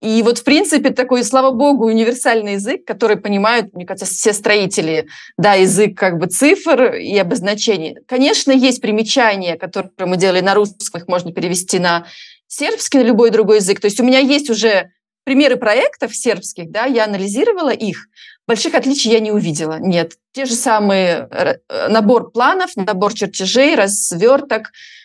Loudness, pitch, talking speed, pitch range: -14 LUFS, 220 Hz, 155 wpm, 195-255 Hz